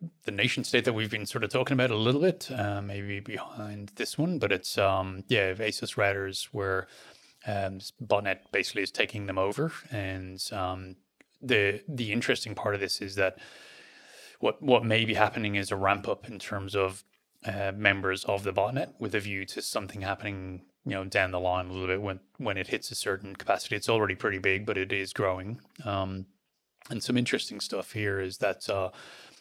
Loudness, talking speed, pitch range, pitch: -30 LUFS, 200 wpm, 95-110 Hz, 100 Hz